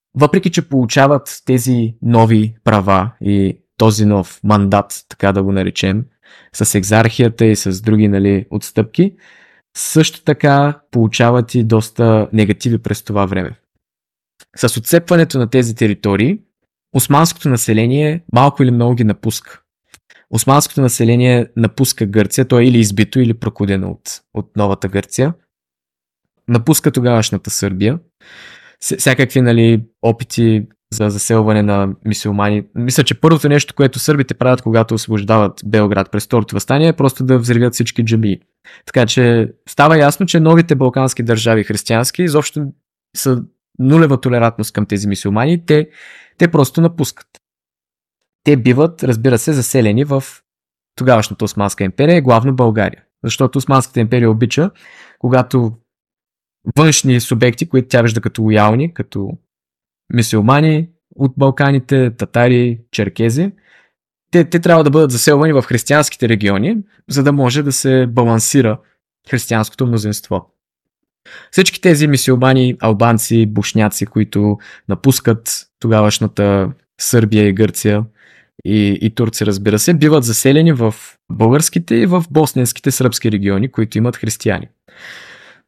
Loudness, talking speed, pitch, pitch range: -13 LUFS, 125 wpm, 120 Hz, 105-135 Hz